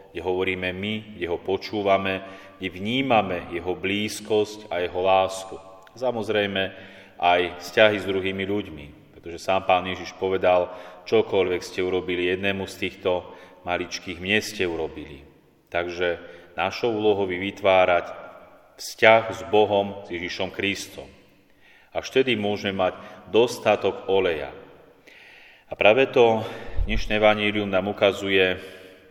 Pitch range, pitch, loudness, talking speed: 90-105 Hz, 95 Hz, -23 LUFS, 120 wpm